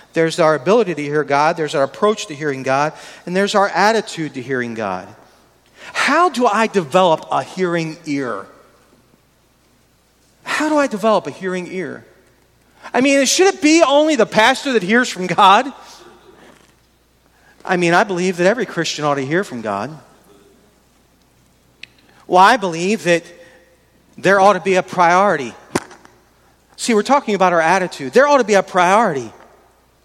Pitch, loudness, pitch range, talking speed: 185 Hz, -16 LUFS, 160-215 Hz, 160 wpm